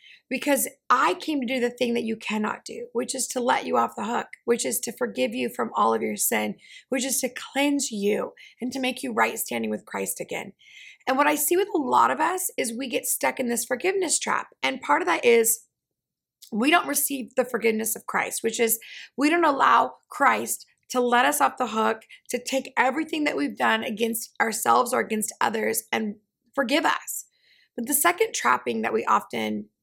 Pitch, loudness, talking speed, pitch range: 255 Hz, -24 LUFS, 210 wpm, 230-285 Hz